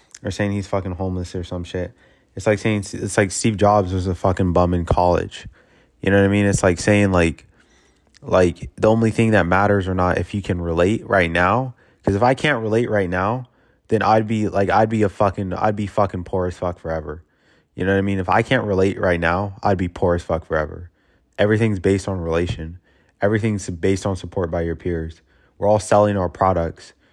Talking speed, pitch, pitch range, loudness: 220 wpm, 95 Hz, 90-105 Hz, -20 LUFS